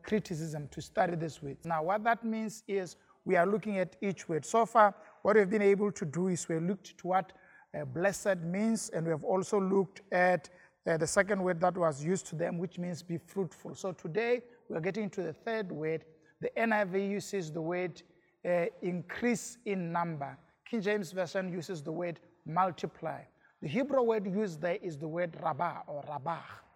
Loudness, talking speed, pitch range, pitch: -33 LUFS, 195 wpm, 165-205 Hz, 185 Hz